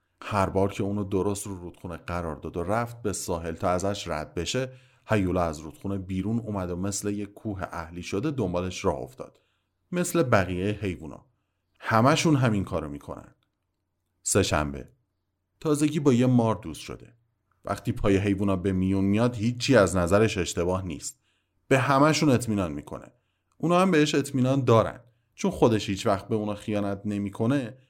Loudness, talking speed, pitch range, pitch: -26 LUFS, 155 wpm, 90-120 Hz, 100 Hz